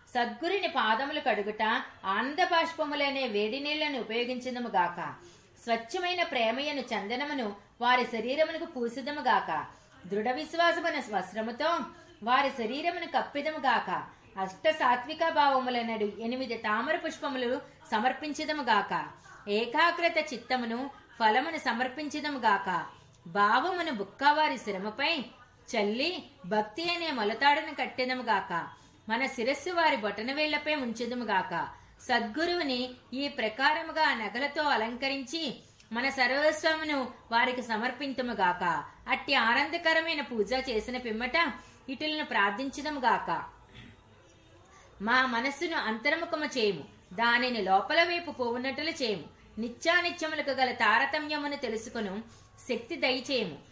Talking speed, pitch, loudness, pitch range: 90 wpm, 260 Hz, -30 LUFS, 225-305 Hz